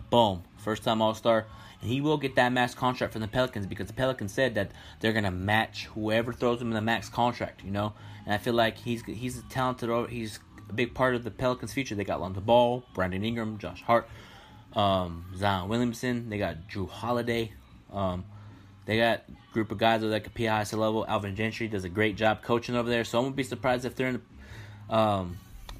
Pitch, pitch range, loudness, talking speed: 110 Hz, 100-120 Hz, -29 LUFS, 215 wpm